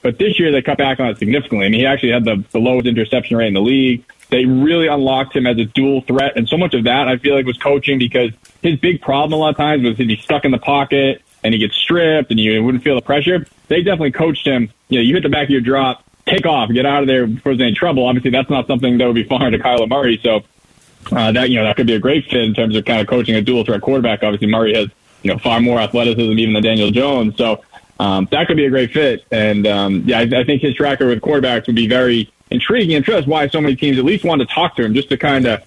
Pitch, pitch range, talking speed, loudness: 125 Hz, 115-140 Hz, 290 wpm, -14 LUFS